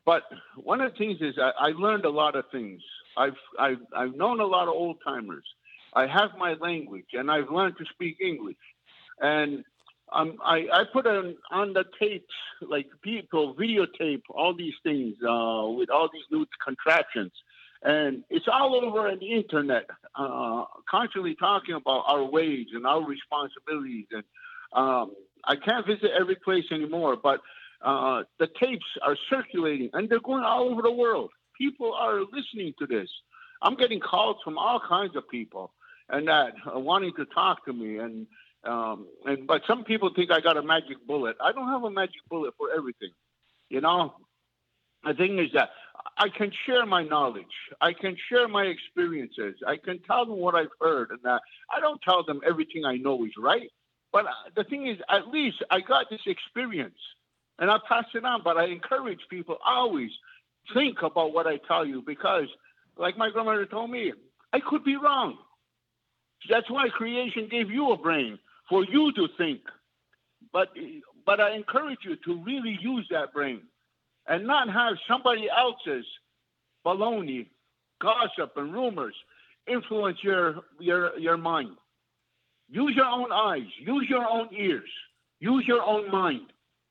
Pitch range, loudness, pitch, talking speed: 160-250 Hz, -27 LUFS, 200 Hz, 170 wpm